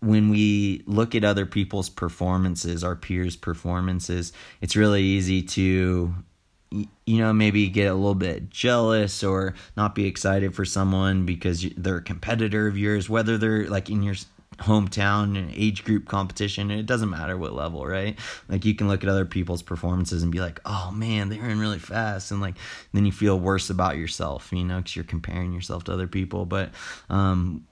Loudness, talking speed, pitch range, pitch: -25 LUFS, 185 wpm, 90-105 Hz, 95 Hz